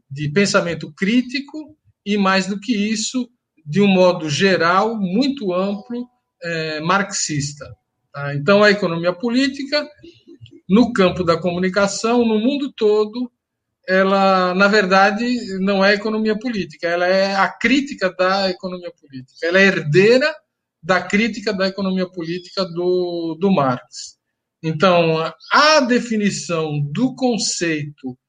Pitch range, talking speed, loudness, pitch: 170-230 Hz, 125 wpm, -17 LUFS, 195 Hz